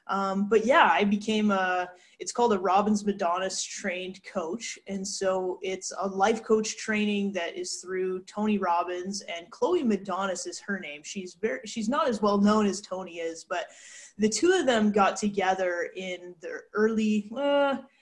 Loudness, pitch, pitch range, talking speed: -27 LUFS, 195 Hz, 185-215 Hz, 170 wpm